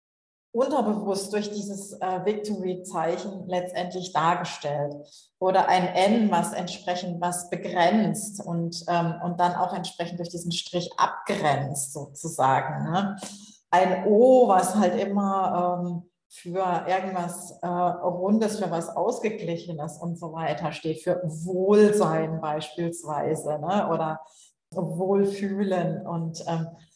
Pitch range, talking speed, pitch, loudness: 170-195 Hz, 115 wpm, 180 Hz, -26 LUFS